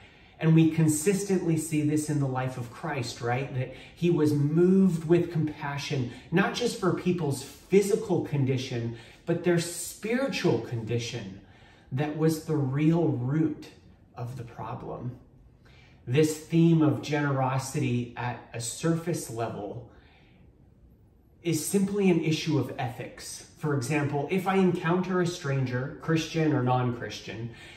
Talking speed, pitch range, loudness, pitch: 130 wpm, 125-165 Hz, -27 LUFS, 150 Hz